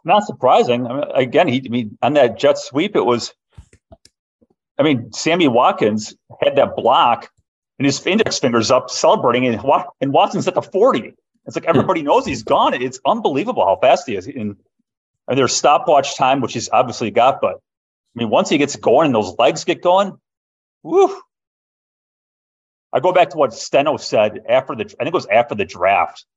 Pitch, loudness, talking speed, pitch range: 130 Hz, -16 LUFS, 190 wpm, 120-180 Hz